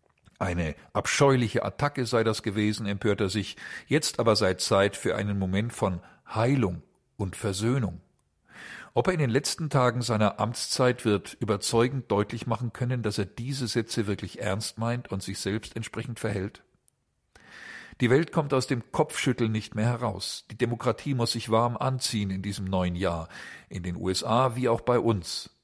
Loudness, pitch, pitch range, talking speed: -27 LUFS, 115 Hz, 100-125 Hz, 165 wpm